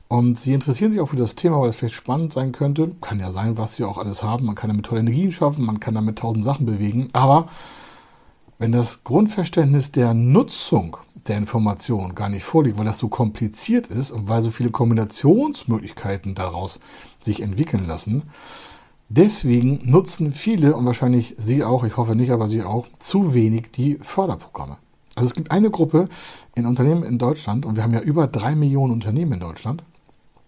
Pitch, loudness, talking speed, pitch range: 120 Hz, -20 LUFS, 185 wpm, 110-150 Hz